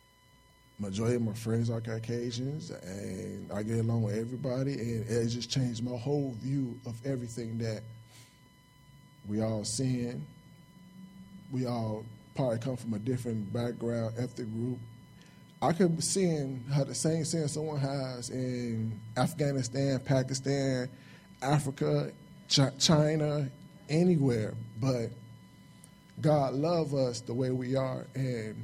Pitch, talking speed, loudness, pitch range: 130 Hz, 130 wpm, -32 LUFS, 115-145 Hz